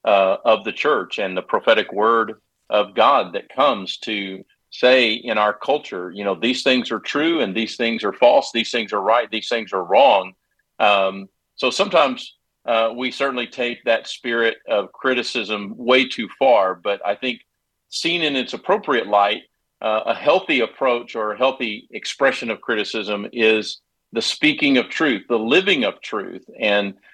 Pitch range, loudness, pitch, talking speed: 105-125 Hz, -19 LUFS, 115 Hz, 170 wpm